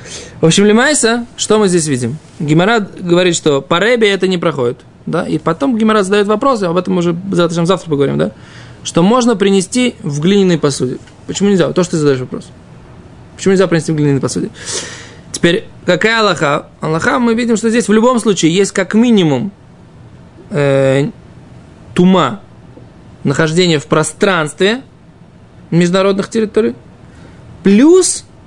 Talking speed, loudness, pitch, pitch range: 150 wpm, -12 LUFS, 185 Hz, 155-215 Hz